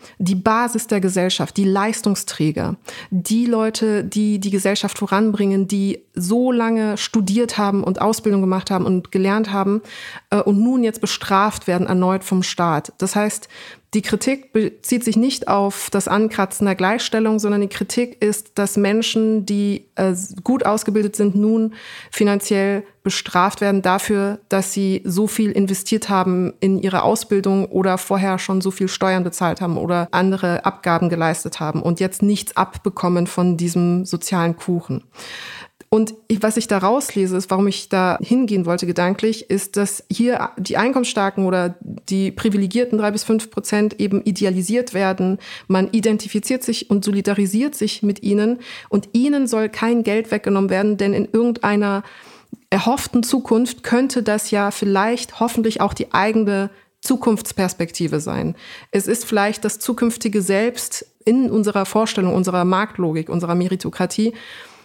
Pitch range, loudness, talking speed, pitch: 190-220 Hz, -19 LUFS, 145 wpm, 205 Hz